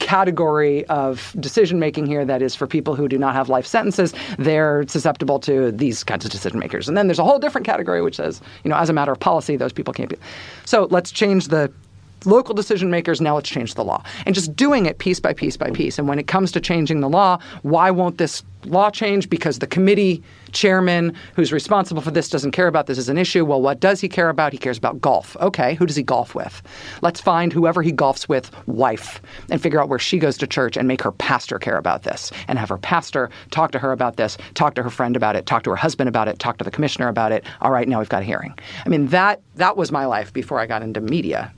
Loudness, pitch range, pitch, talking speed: -19 LUFS, 130-180 Hz, 155 Hz, 255 wpm